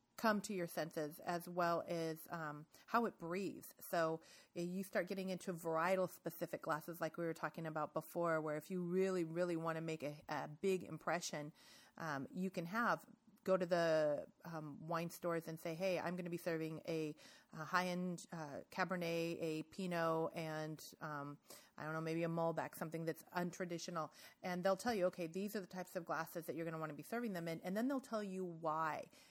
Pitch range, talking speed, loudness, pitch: 160-185 Hz, 205 wpm, -43 LUFS, 170 Hz